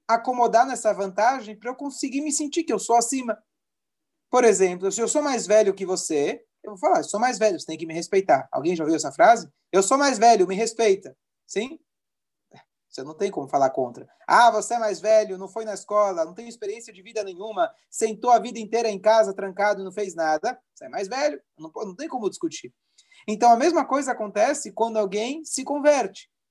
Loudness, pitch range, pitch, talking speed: -23 LUFS, 200-275 Hz, 225 Hz, 215 wpm